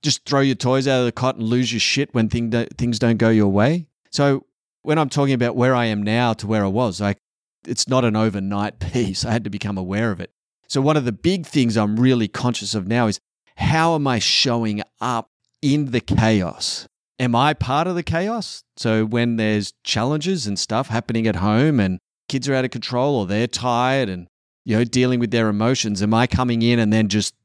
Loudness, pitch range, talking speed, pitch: -20 LUFS, 110-130 Hz, 225 wpm, 120 Hz